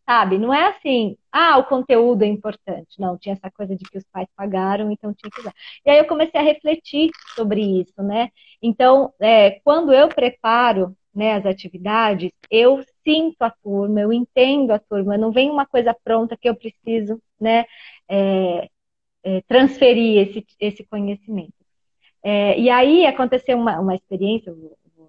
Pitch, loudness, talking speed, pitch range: 225 Hz, -18 LUFS, 165 wpm, 200-255 Hz